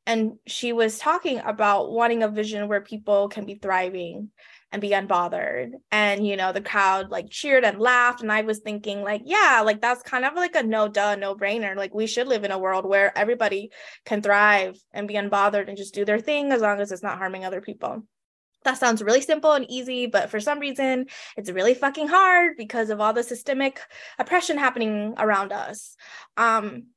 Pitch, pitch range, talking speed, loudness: 215 Hz, 200-245 Hz, 205 wpm, -23 LUFS